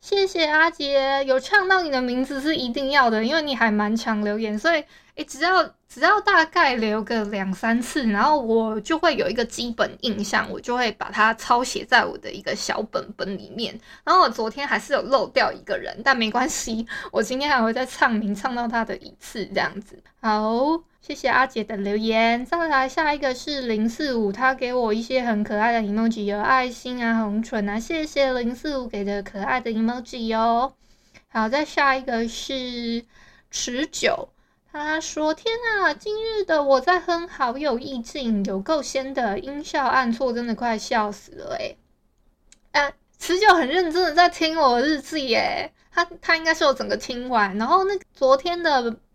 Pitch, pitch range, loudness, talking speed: 255 Hz, 225-305 Hz, -22 LUFS, 270 characters per minute